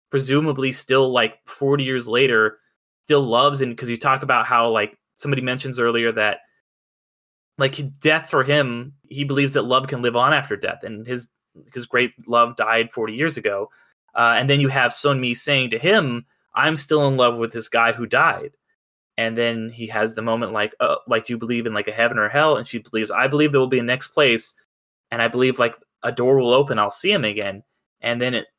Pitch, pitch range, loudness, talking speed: 125 Hz, 115-140 Hz, -20 LUFS, 220 wpm